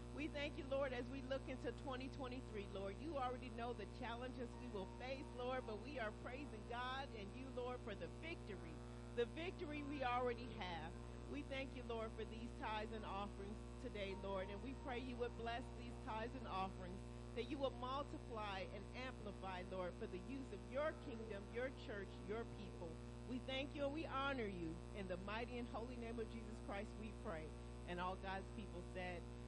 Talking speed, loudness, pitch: 195 wpm, -49 LUFS, 85 Hz